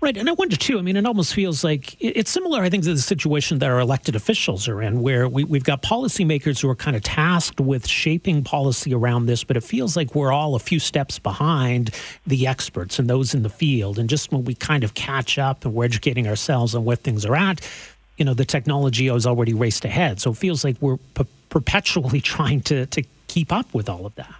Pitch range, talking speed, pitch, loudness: 125-160 Hz, 240 wpm, 140 Hz, -21 LUFS